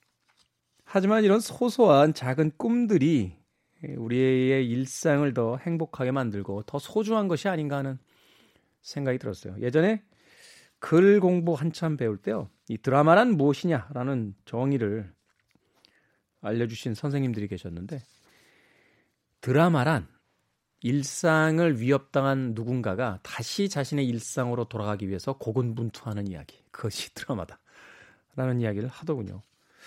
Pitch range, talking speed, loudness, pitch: 115-160 Hz, 285 characters per minute, -26 LUFS, 135 Hz